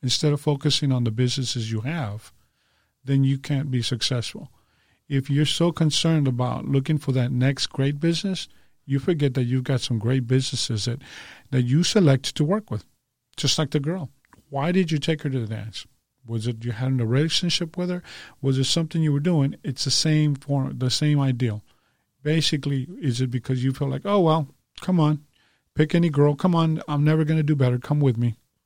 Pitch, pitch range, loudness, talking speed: 140 Hz, 125-155 Hz, -23 LUFS, 205 wpm